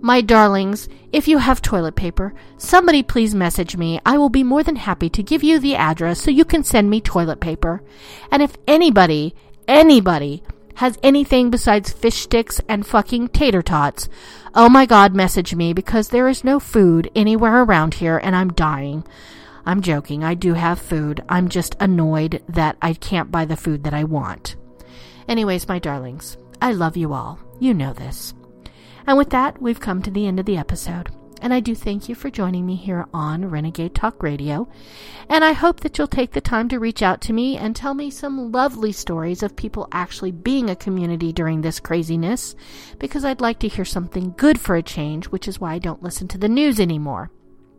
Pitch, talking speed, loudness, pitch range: 190 Hz, 200 wpm, -18 LUFS, 165-245 Hz